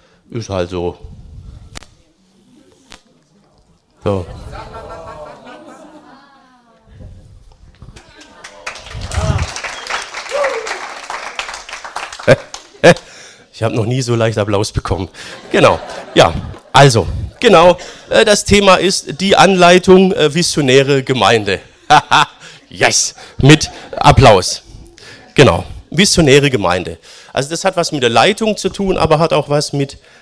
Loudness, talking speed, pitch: -12 LUFS, 95 wpm, 145 Hz